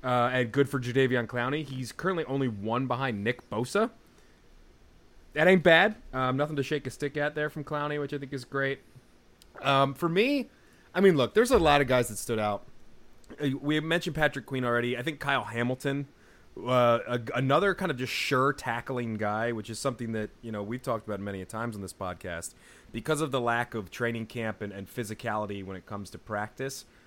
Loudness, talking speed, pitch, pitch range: -29 LUFS, 205 wpm, 125 Hz, 115-145 Hz